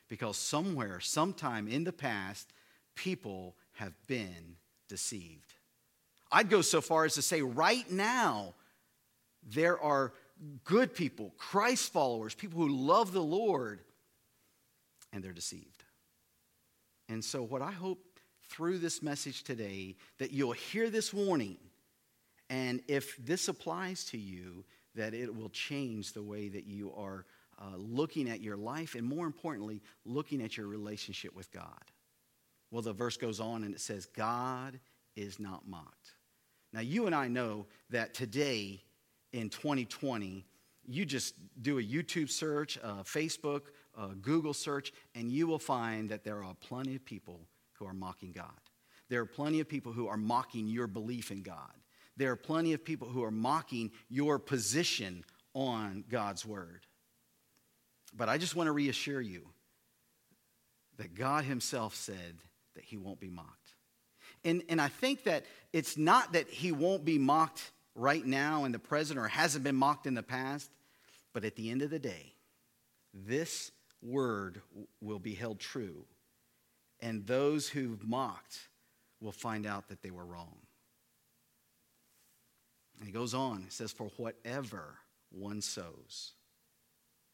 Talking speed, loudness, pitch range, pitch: 150 wpm, -36 LUFS, 105-145 Hz, 120 Hz